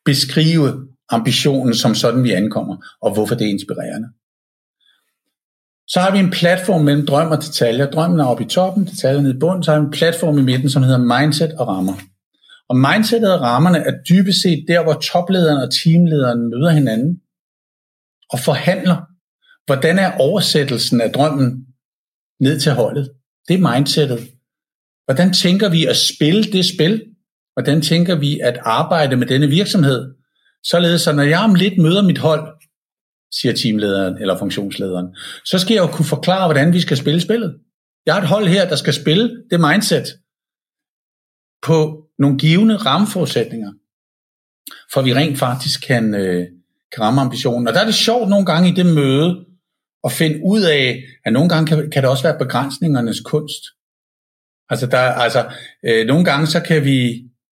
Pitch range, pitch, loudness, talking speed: 125-175 Hz, 150 Hz, -15 LUFS, 170 wpm